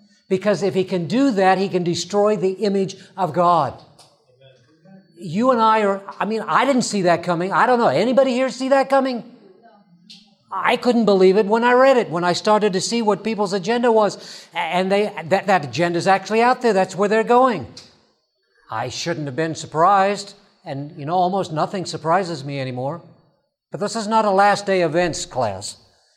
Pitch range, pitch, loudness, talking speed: 170-215 Hz, 190 Hz, -19 LUFS, 195 wpm